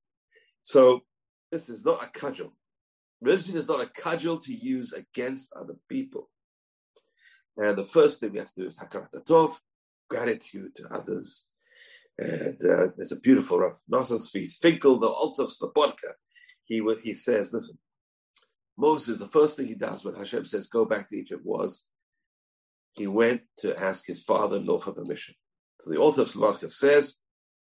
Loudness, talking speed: -26 LUFS, 165 wpm